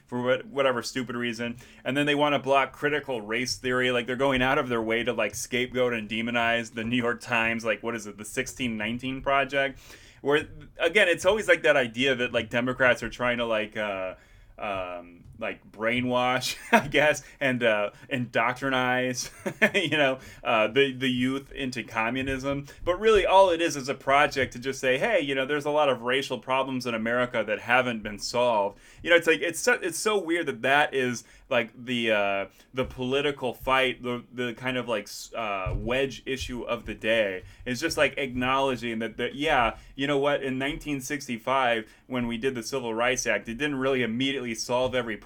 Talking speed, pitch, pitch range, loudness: 195 wpm, 125 Hz, 120-135 Hz, -26 LUFS